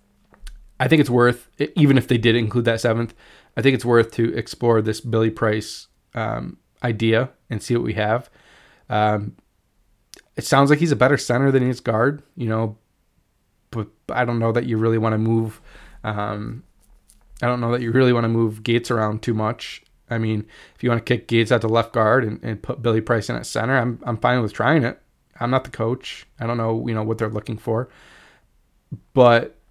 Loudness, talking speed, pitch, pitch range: -21 LUFS, 210 wpm, 115 Hz, 110-125 Hz